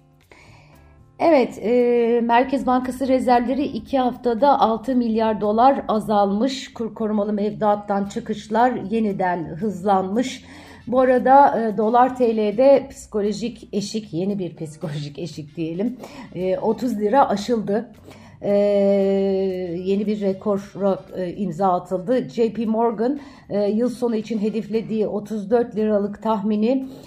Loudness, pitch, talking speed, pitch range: -21 LUFS, 220 Hz, 110 wpm, 200-245 Hz